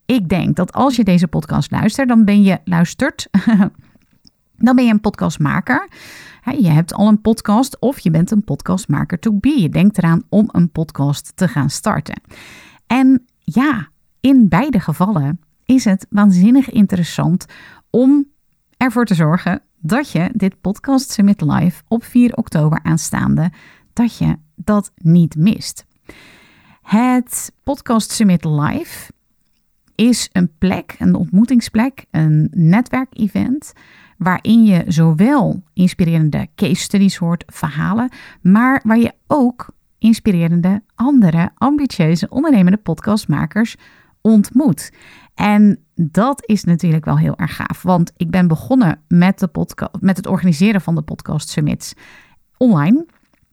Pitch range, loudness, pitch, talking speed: 175-235 Hz, -15 LUFS, 200 Hz, 130 wpm